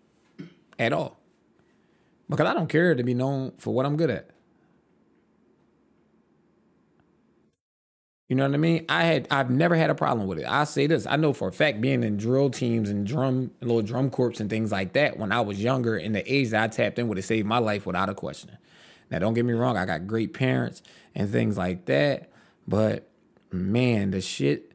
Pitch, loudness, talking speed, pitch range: 120 Hz, -25 LUFS, 205 wpm, 100-135 Hz